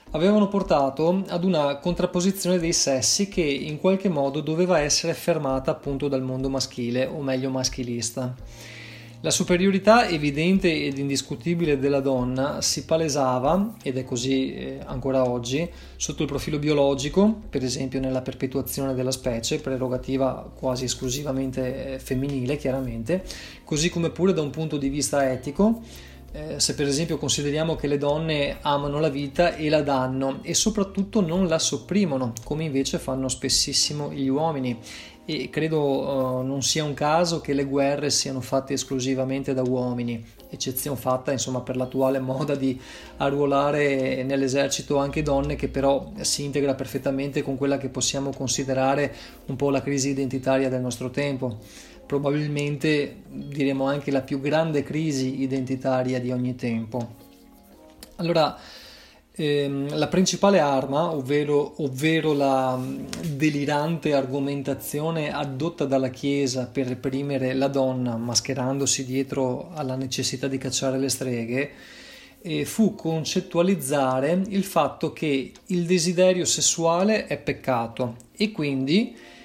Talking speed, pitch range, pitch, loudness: 135 wpm, 130-155 Hz, 140 Hz, -24 LUFS